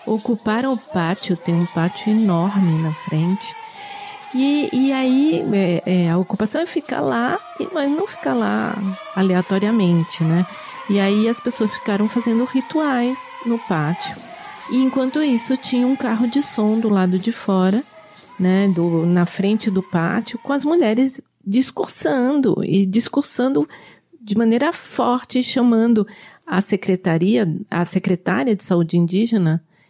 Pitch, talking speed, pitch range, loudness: 215 Hz, 140 wpm, 185-255 Hz, -19 LUFS